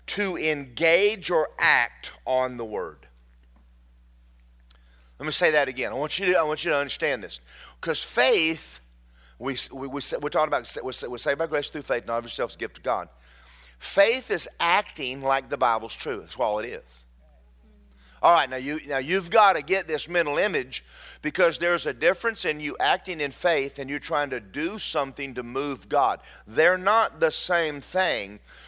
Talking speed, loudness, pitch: 185 wpm, -25 LUFS, 135 Hz